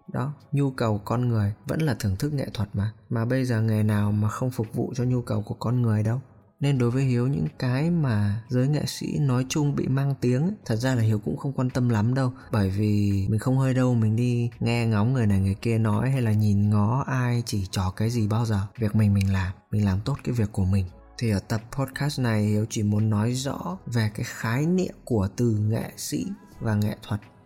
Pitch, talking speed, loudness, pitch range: 115 Hz, 245 wpm, -25 LUFS, 105-130 Hz